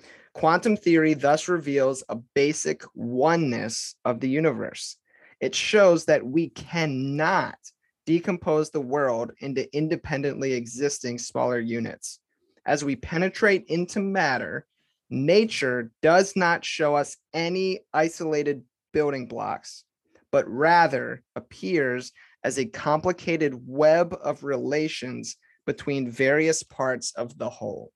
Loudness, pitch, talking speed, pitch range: -25 LUFS, 150 Hz, 110 wpm, 135-165 Hz